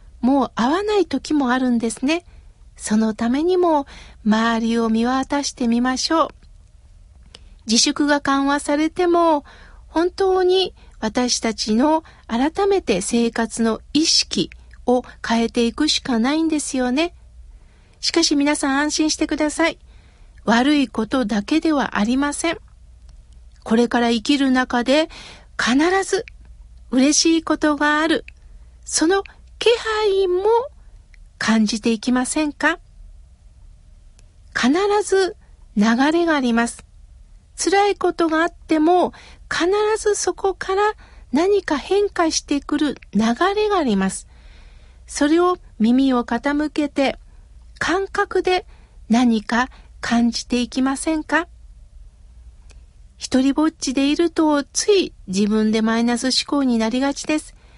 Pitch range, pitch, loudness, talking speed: 235-330 Hz, 285 Hz, -19 LUFS, 230 characters per minute